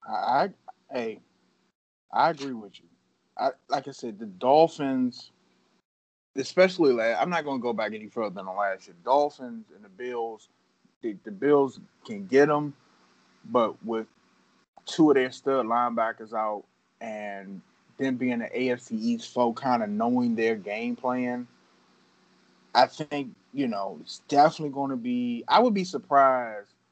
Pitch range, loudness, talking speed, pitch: 105-145 Hz, -26 LUFS, 155 wpm, 125 Hz